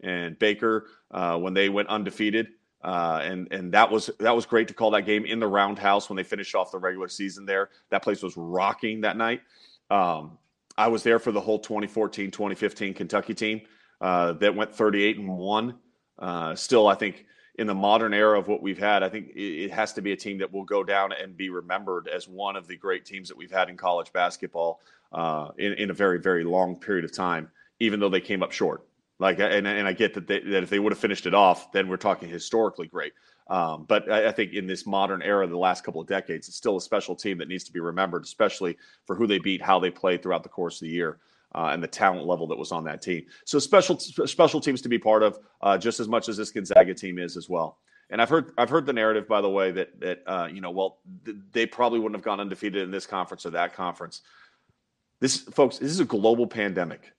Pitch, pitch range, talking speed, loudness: 100 Hz, 95-110 Hz, 240 wpm, -26 LUFS